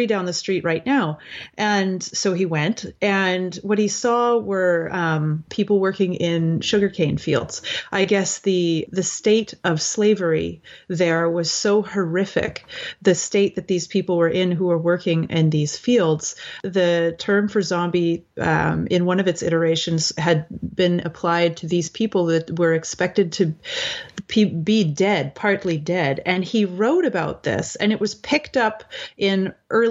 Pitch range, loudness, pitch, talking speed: 170-205 Hz, -21 LUFS, 185 Hz, 160 wpm